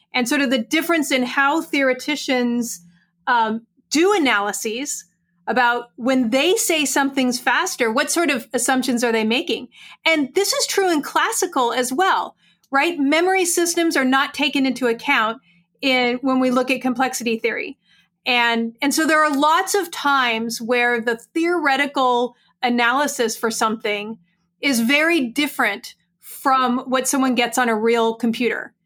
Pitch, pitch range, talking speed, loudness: 260 Hz, 235-290 Hz, 150 wpm, -19 LUFS